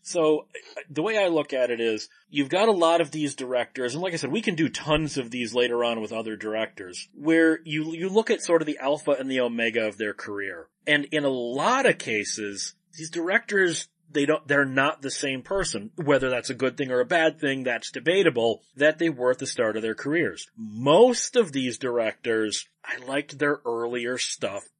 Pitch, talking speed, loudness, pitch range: 140 Hz, 215 wpm, -25 LUFS, 120-160 Hz